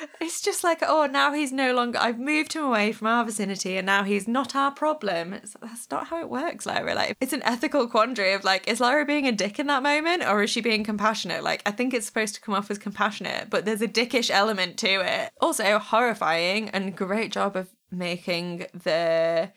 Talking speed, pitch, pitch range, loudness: 225 wpm, 225 Hz, 195-280 Hz, -24 LUFS